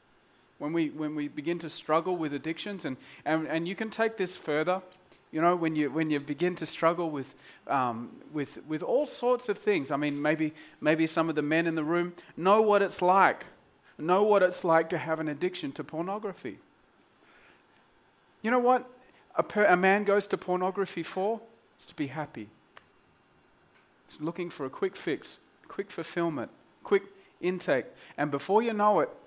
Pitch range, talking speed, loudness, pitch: 155-195 Hz, 180 wpm, -29 LUFS, 170 Hz